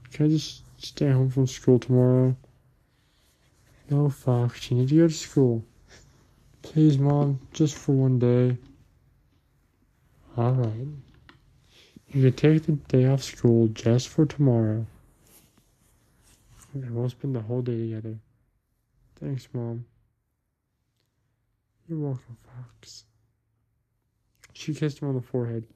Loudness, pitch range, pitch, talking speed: -24 LUFS, 115-135 Hz, 125 Hz, 120 wpm